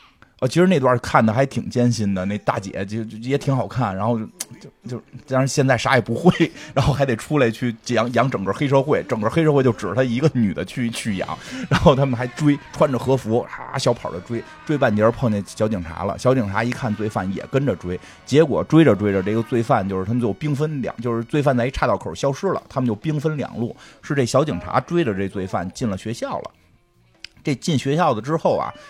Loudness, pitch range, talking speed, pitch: -21 LUFS, 110-140 Hz, 325 characters per minute, 120 Hz